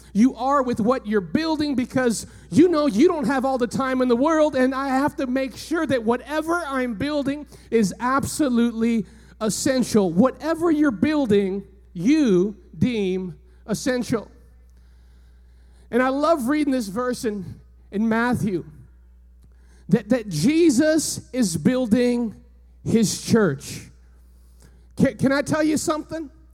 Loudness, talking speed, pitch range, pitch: -22 LUFS, 135 wpm, 185-275 Hz, 240 Hz